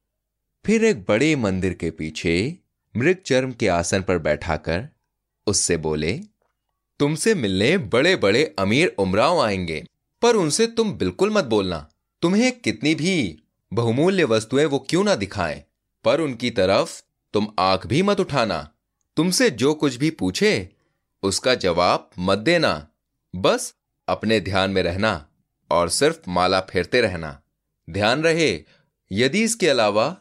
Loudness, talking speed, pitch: -21 LUFS, 135 wpm, 115 Hz